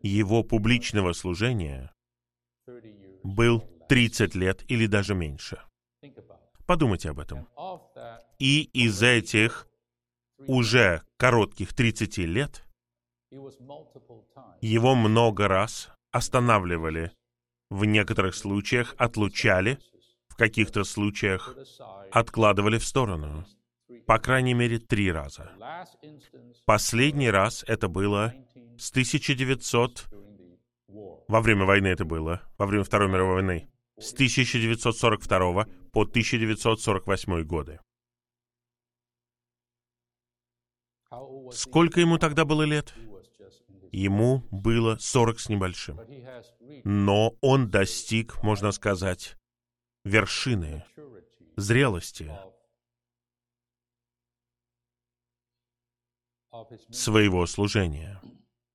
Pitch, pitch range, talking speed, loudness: 115 Hz, 100-120 Hz, 80 wpm, -25 LUFS